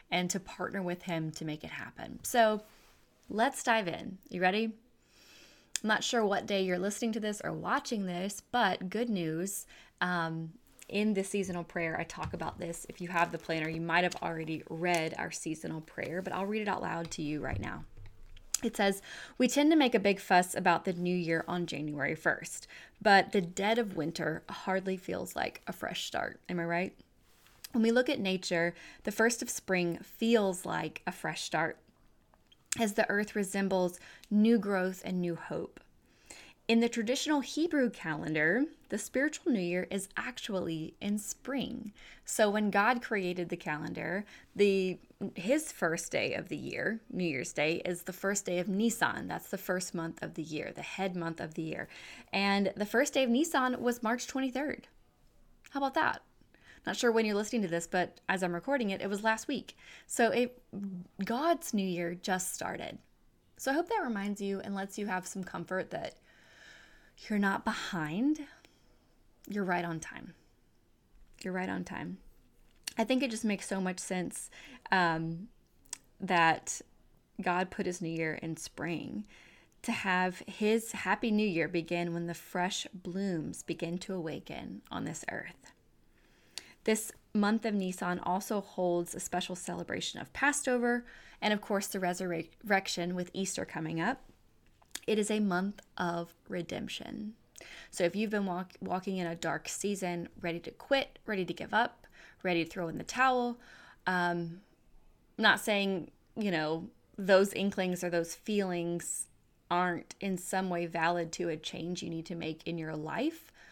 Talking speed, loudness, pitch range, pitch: 175 wpm, -33 LUFS, 170-220 Hz, 190 Hz